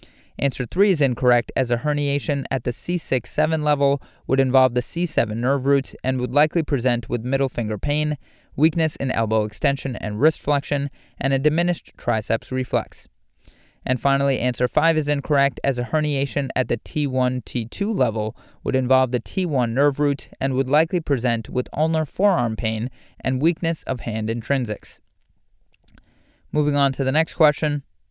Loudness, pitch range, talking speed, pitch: -22 LUFS, 125-150 Hz, 165 wpm, 135 Hz